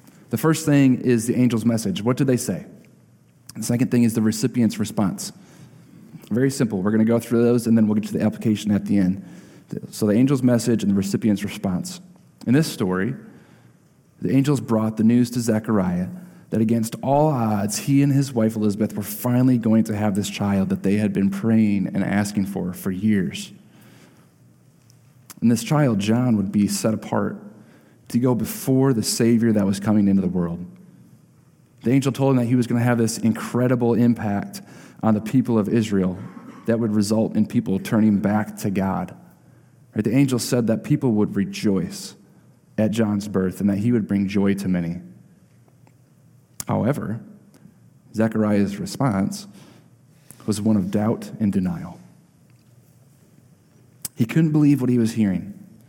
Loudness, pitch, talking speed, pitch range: -21 LUFS, 115 Hz, 170 wpm, 105-130 Hz